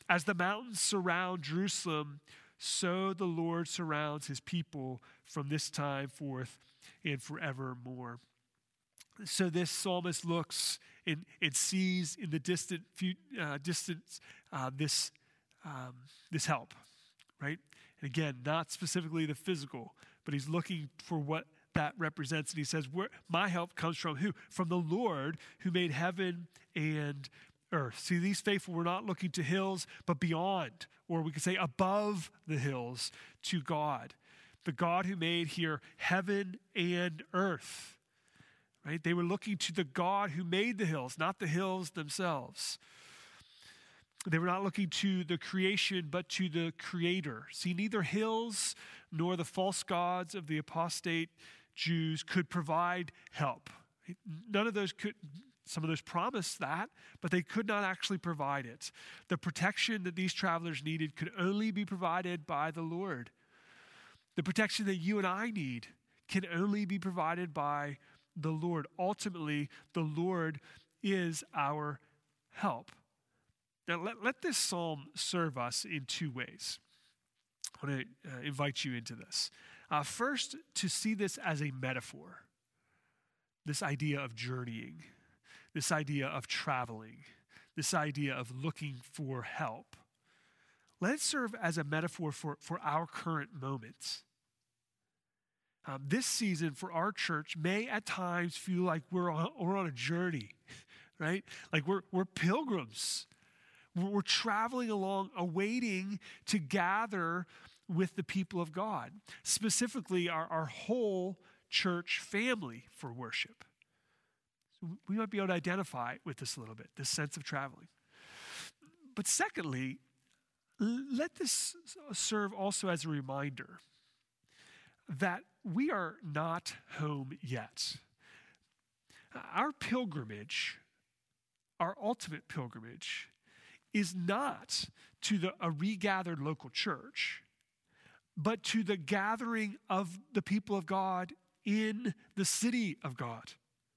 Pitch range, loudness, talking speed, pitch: 150-195 Hz, -36 LUFS, 135 wpm, 175 Hz